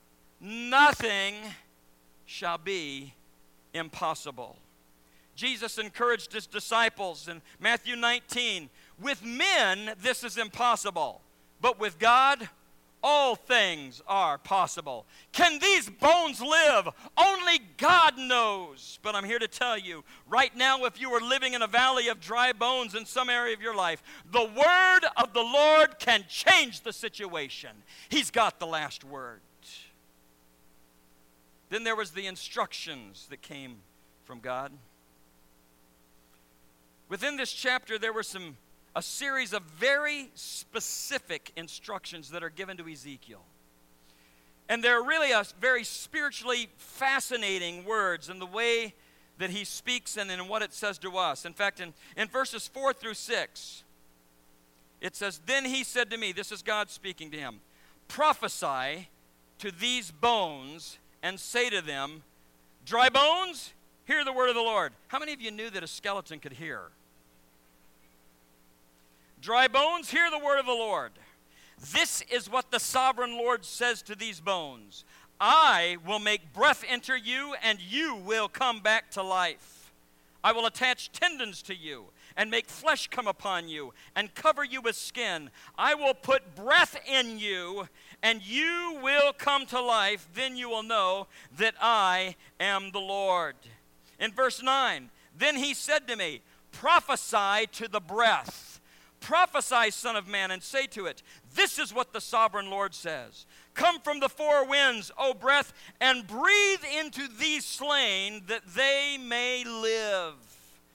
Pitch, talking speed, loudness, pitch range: 215 Hz, 150 wpm, -27 LUFS, 160-255 Hz